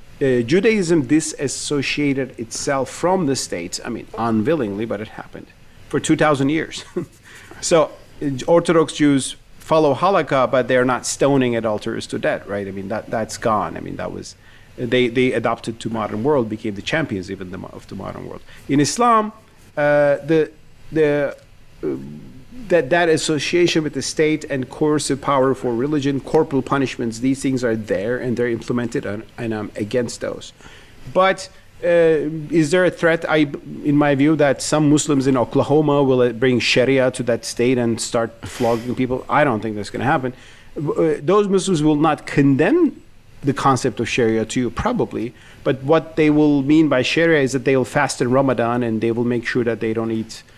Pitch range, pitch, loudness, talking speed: 115-150 Hz, 135 Hz, -19 LUFS, 185 wpm